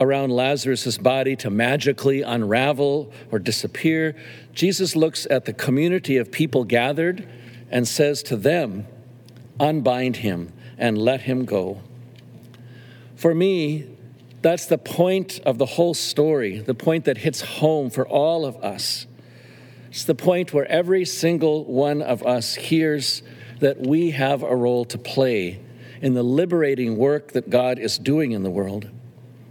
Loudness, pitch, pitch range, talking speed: -21 LUFS, 130 Hz, 120-150 Hz, 145 wpm